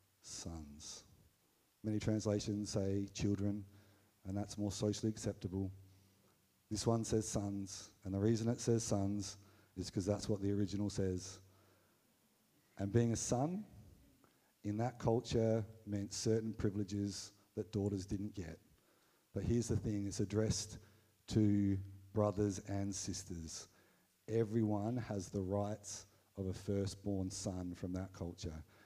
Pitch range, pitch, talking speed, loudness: 95-110 Hz, 100 Hz, 130 wpm, -40 LUFS